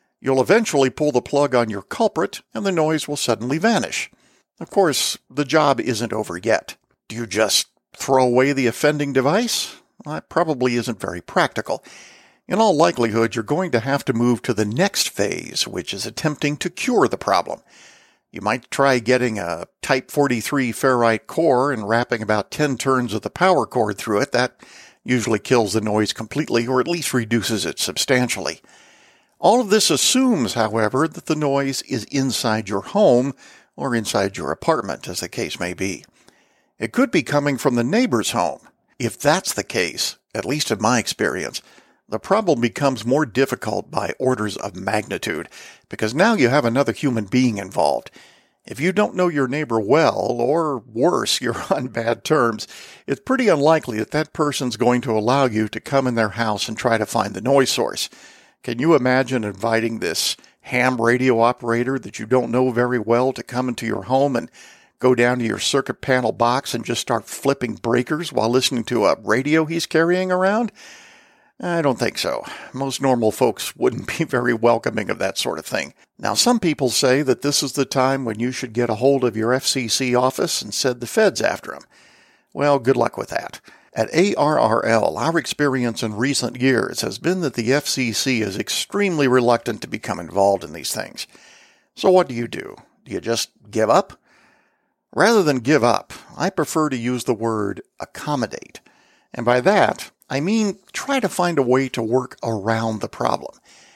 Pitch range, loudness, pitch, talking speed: 115-140 Hz, -20 LUFS, 125 Hz, 185 wpm